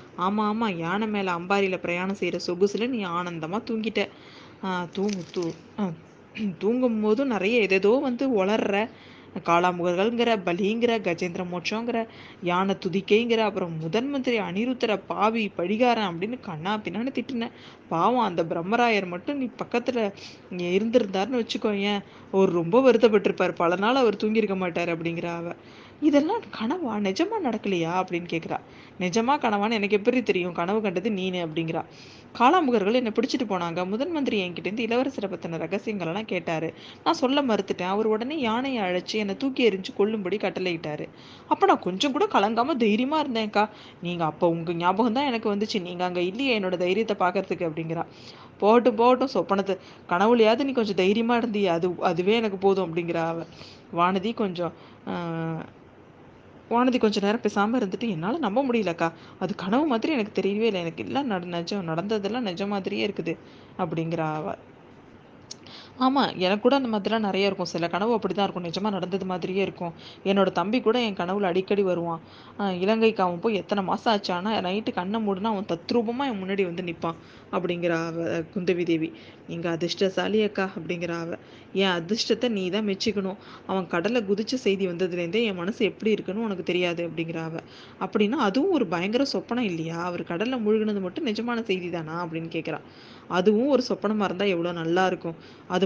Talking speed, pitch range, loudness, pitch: 150 wpm, 180-225 Hz, -25 LUFS, 200 Hz